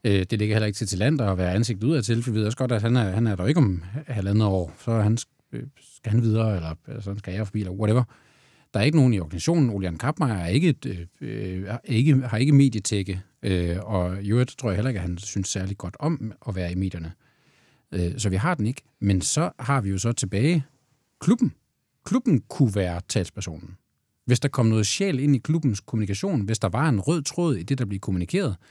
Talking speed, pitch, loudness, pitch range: 230 wpm, 110 Hz, -24 LUFS, 95-135 Hz